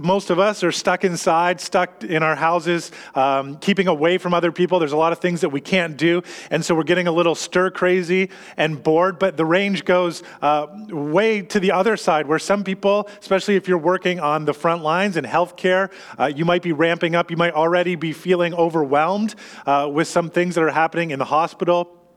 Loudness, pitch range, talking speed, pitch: -19 LUFS, 160-185 Hz, 215 wpm, 175 Hz